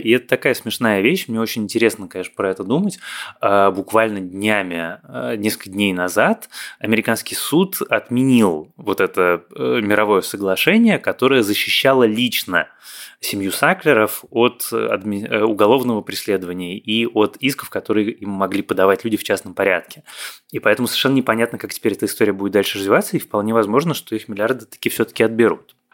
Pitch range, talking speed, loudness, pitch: 100-115 Hz, 145 wpm, -18 LUFS, 105 Hz